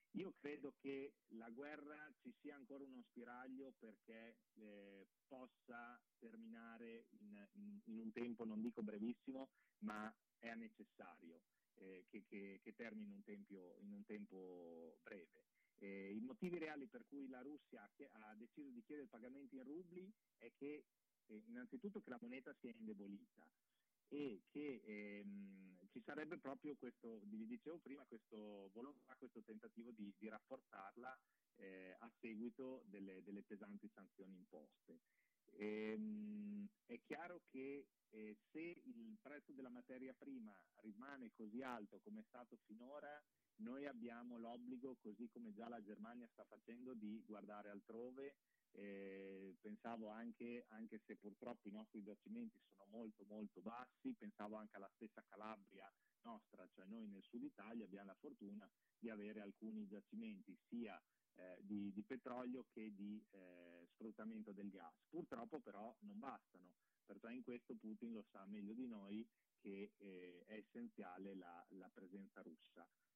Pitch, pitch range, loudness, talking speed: 115 Hz, 105-145 Hz, -57 LUFS, 150 wpm